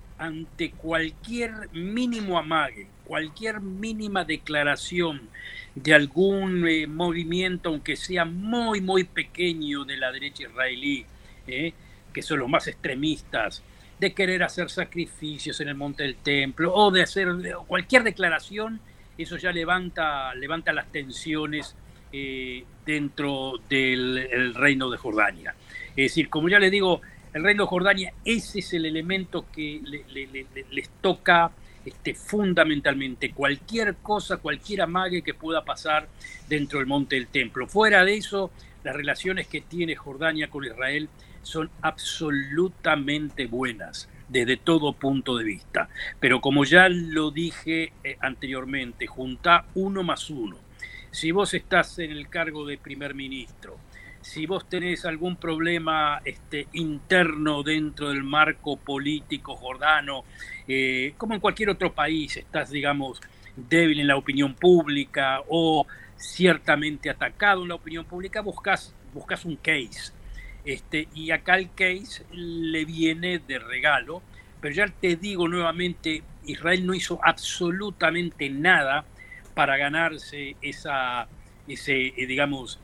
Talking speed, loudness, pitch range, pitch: 135 wpm, -25 LUFS, 140-180 Hz, 155 Hz